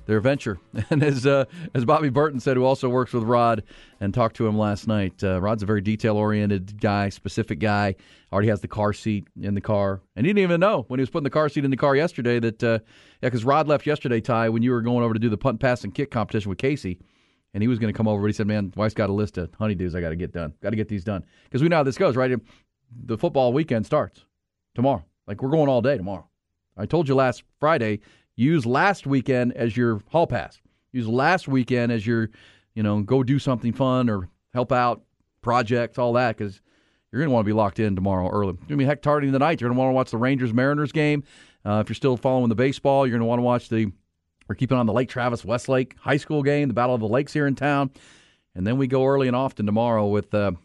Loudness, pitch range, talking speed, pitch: -23 LUFS, 105-135 Hz, 255 wpm, 120 Hz